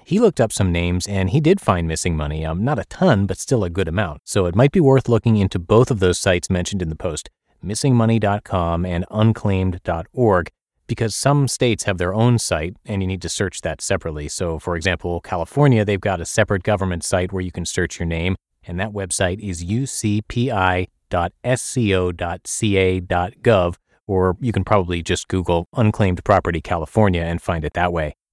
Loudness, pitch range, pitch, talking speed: -20 LUFS, 90-110 Hz, 95 Hz, 185 wpm